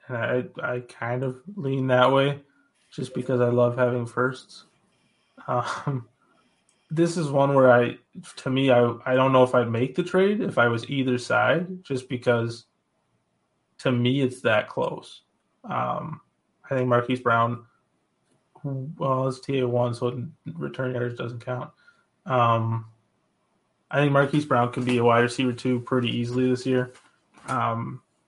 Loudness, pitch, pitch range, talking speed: -24 LUFS, 125 Hz, 120-135 Hz, 155 wpm